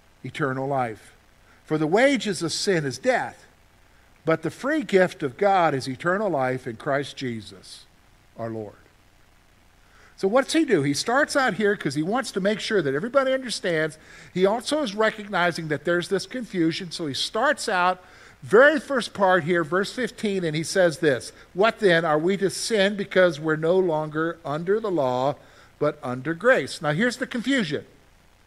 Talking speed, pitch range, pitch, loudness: 175 wpm, 135-205 Hz, 170 Hz, -23 LUFS